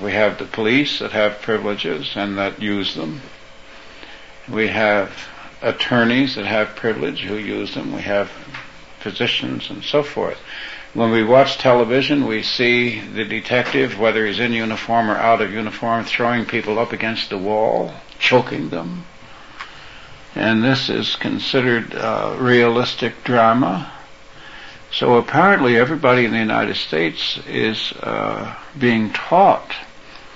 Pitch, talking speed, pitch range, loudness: 115 Hz, 135 wpm, 105-125 Hz, -18 LUFS